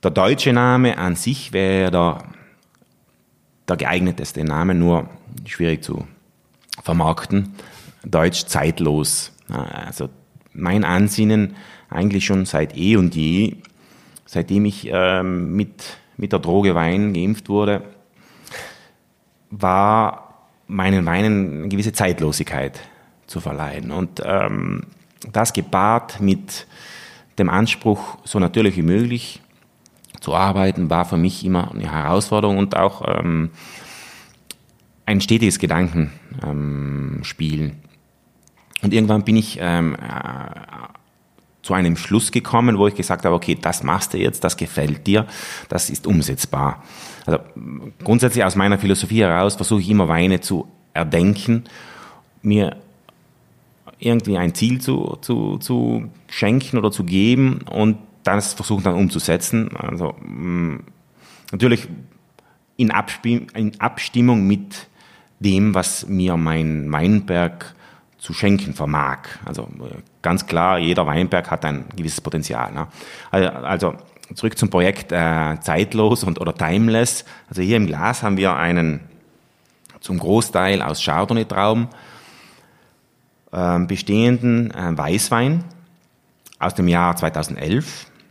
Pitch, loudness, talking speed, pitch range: 95 Hz, -19 LUFS, 120 wpm, 85-110 Hz